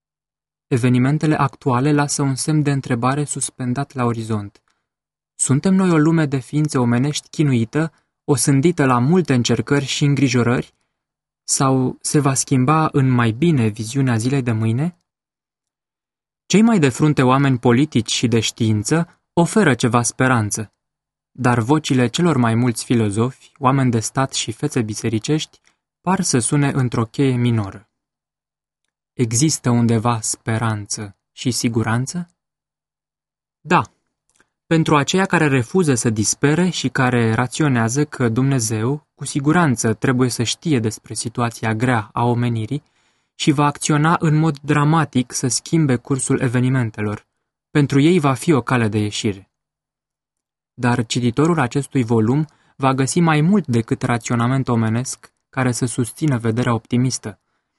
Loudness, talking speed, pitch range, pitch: -18 LUFS, 130 wpm, 120-150 Hz, 130 Hz